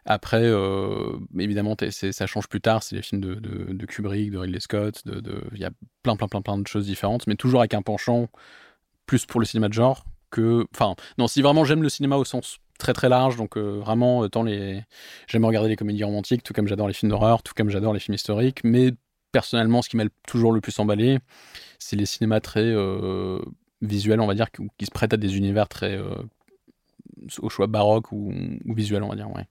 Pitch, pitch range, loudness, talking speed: 105 Hz, 100-115 Hz, -24 LUFS, 230 wpm